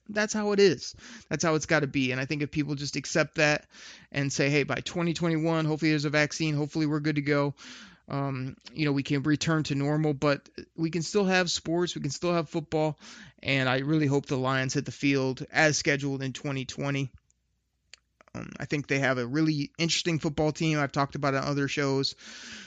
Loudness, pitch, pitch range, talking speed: -28 LUFS, 150 Hz, 140-160 Hz, 210 wpm